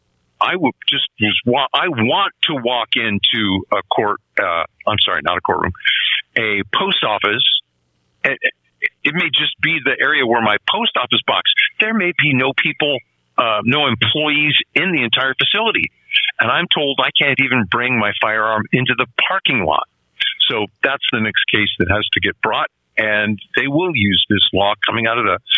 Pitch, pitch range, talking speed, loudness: 120 Hz, 100-150 Hz, 180 wpm, -16 LUFS